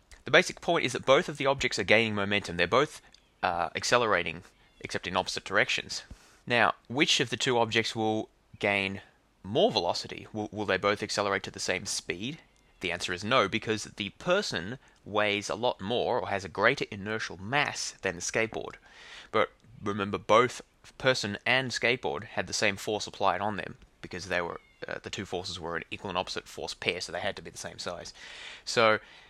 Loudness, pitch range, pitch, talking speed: -29 LUFS, 100-115 Hz, 105 Hz, 195 wpm